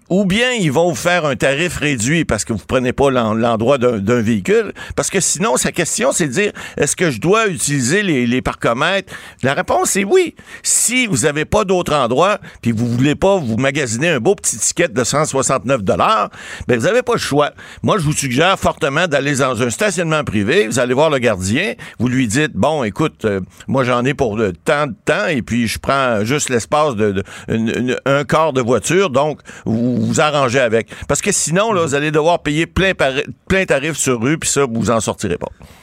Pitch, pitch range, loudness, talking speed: 140 Hz, 120-175 Hz, -16 LUFS, 220 wpm